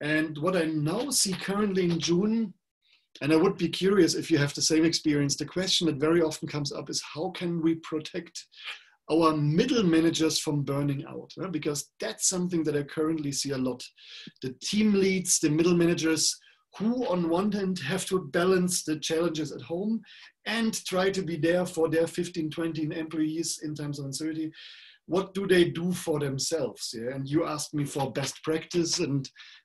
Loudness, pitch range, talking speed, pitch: -27 LUFS, 155-180 Hz, 190 wpm, 165 Hz